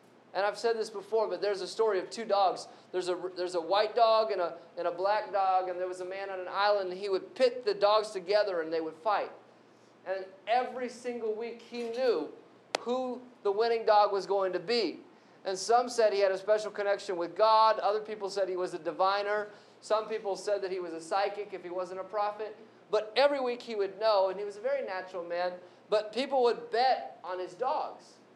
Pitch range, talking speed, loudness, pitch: 185-220 Hz, 225 wpm, -31 LUFS, 205 Hz